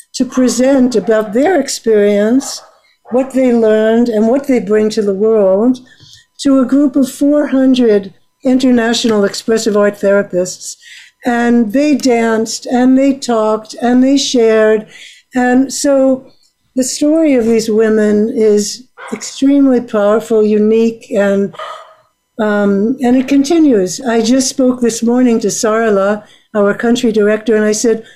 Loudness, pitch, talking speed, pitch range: -12 LUFS, 235 Hz, 130 wpm, 215-260 Hz